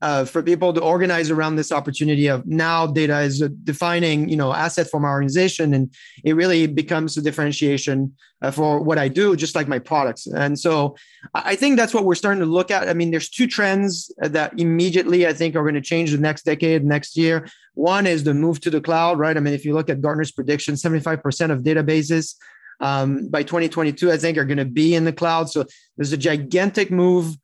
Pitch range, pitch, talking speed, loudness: 150-170 Hz, 160 Hz, 220 wpm, -20 LUFS